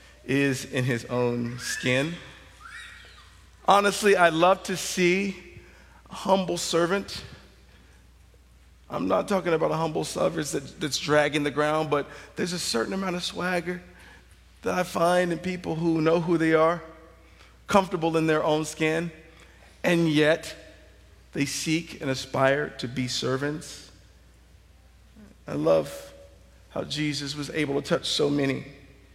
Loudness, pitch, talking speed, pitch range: -25 LUFS, 150 Hz, 135 wpm, 120-170 Hz